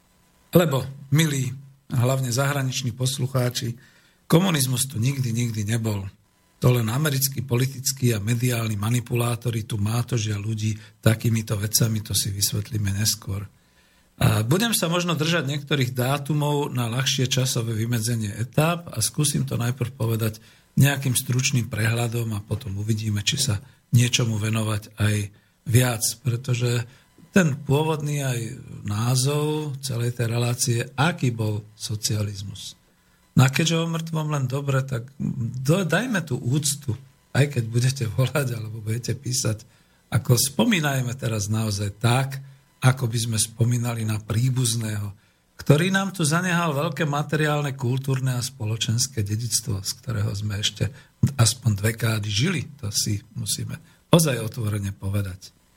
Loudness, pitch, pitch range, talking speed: -24 LUFS, 120 Hz, 110-140 Hz, 130 wpm